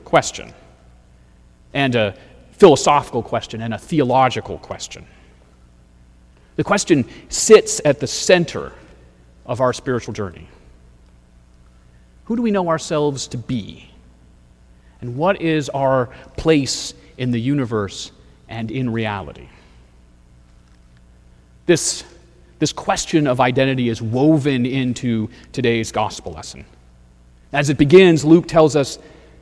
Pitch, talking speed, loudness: 110 Hz, 110 wpm, -17 LUFS